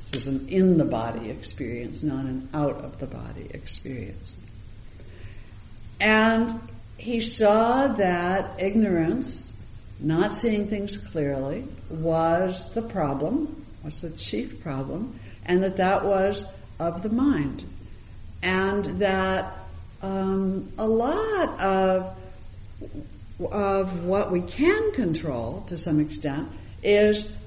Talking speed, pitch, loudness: 110 wpm, 175 Hz, -25 LUFS